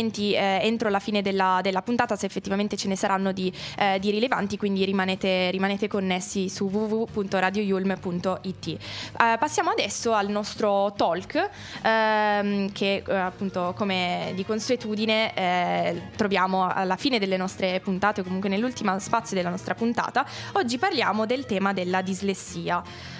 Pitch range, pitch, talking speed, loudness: 190-215 Hz, 200 Hz, 140 wpm, -25 LUFS